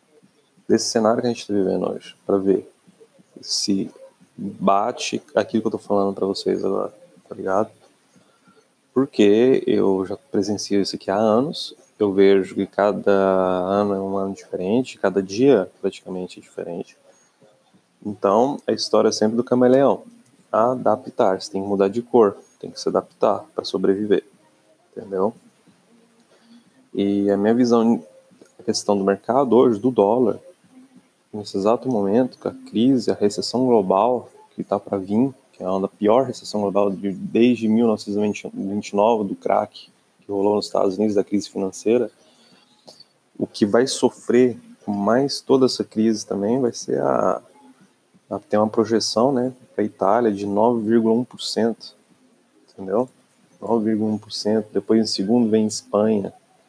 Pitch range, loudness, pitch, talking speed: 100-120 Hz, -20 LUFS, 105 Hz, 145 wpm